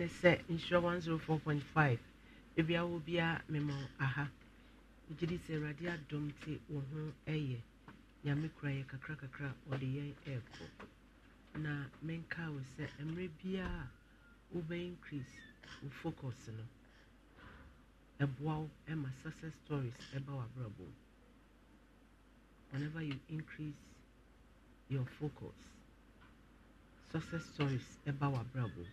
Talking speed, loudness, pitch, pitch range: 110 wpm, -41 LUFS, 145 Hz, 135-160 Hz